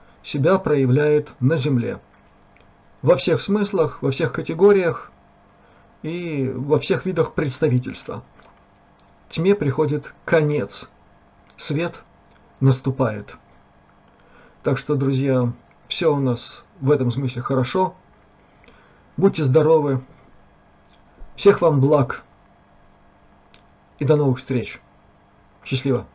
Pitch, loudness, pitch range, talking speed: 135 Hz, -20 LUFS, 125-155 Hz, 90 wpm